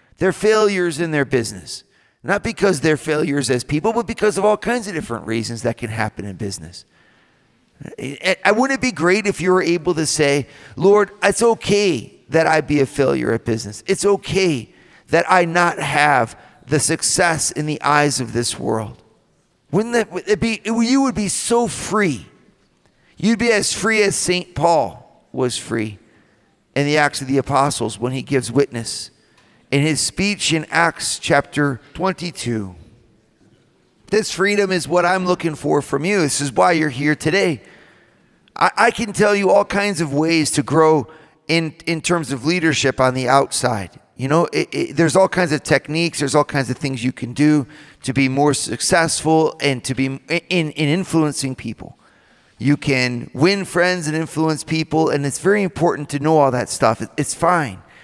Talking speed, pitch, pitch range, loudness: 180 wpm, 155 Hz, 135-180 Hz, -18 LUFS